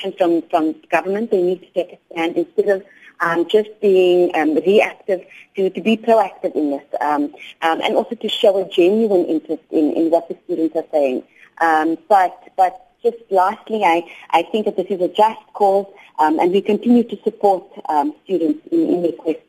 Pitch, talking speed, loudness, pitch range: 185 Hz, 190 wpm, -18 LUFS, 165-205 Hz